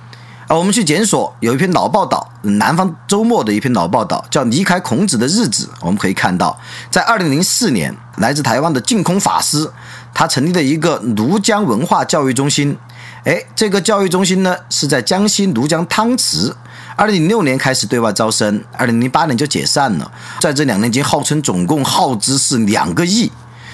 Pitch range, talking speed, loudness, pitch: 125-200 Hz, 295 characters per minute, -14 LUFS, 160 Hz